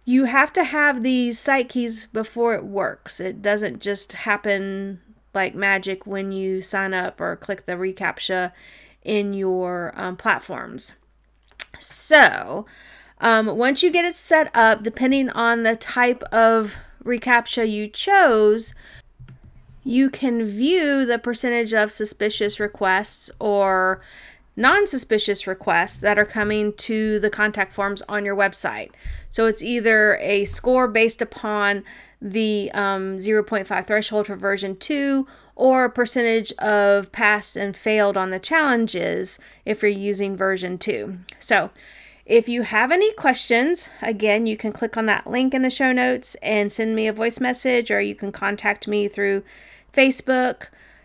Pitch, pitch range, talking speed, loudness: 215 Hz, 200-245 Hz, 145 wpm, -20 LUFS